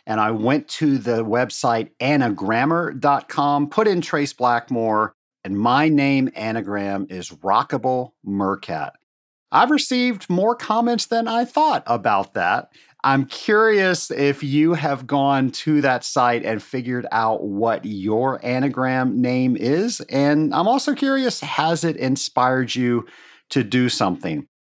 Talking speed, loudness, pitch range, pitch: 135 wpm, -20 LUFS, 120-165 Hz, 135 Hz